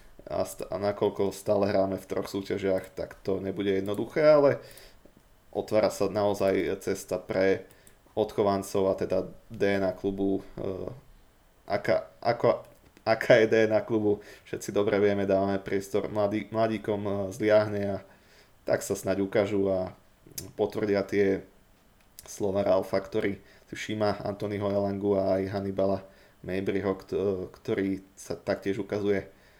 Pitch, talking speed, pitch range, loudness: 100 Hz, 120 wpm, 95-105 Hz, -28 LUFS